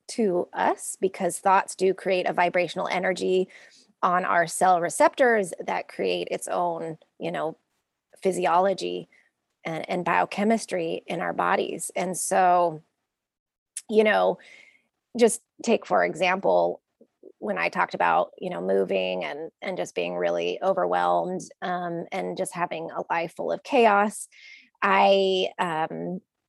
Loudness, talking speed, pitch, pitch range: -25 LUFS, 130 wpm, 180 Hz, 165-195 Hz